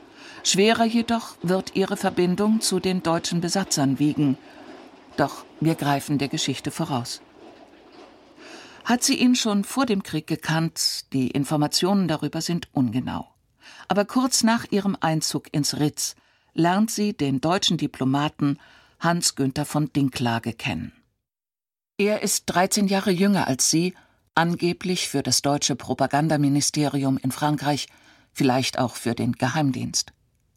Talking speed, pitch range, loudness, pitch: 125 wpm, 140-200 Hz, -23 LUFS, 160 Hz